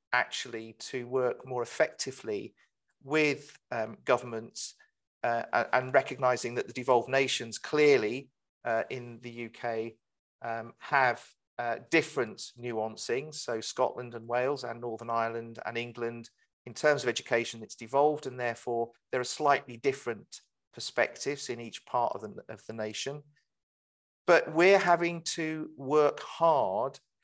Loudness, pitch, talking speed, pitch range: -30 LUFS, 120 Hz, 135 wpm, 115-140 Hz